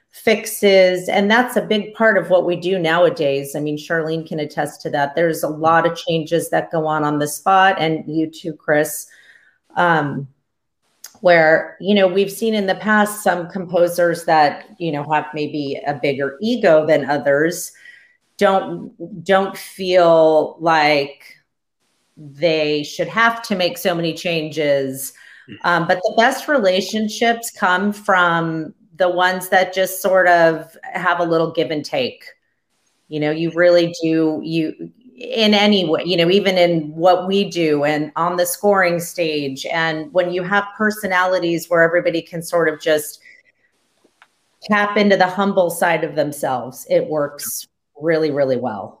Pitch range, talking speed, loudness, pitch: 155-195 Hz, 160 wpm, -17 LUFS, 170 Hz